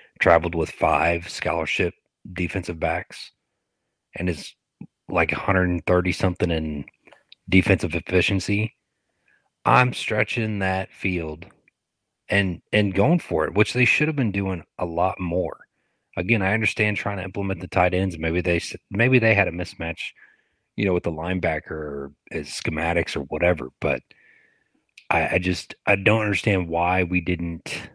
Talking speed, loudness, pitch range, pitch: 145 wpm, -23 LUFS, 85-100 Hz, 90 Hz